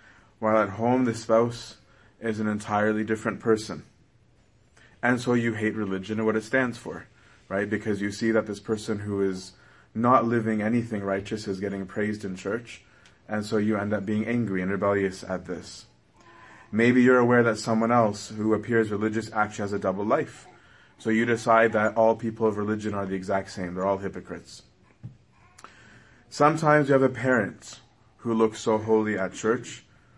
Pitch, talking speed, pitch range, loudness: 110 Hz, 175 wpm, 100-115 Hz, -25 LUFS